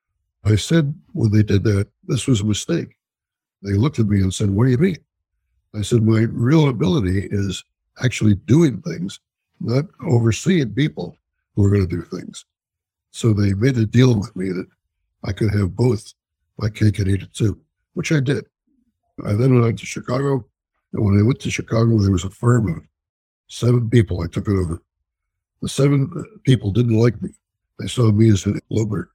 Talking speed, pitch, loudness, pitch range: 195 wpm, 110 Hz, -19 LUFS, 100-130 Hz